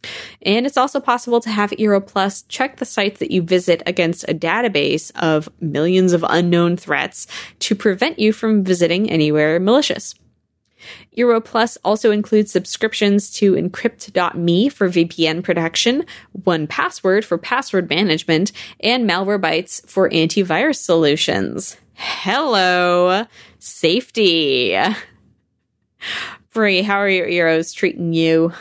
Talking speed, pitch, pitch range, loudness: 115 wpm, 190 Hz, 170-220 Hz, -17 LUFS